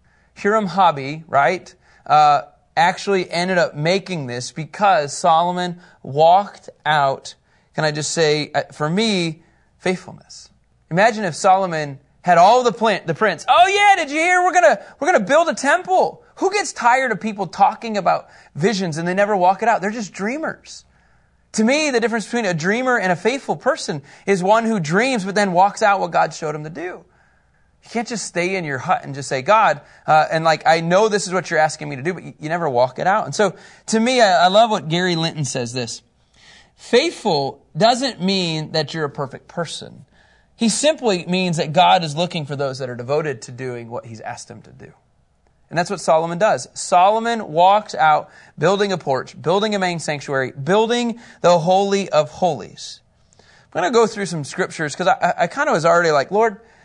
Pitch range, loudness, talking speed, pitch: 155-220 Hz, -18 LUFS, 200 wpm, 180 Hz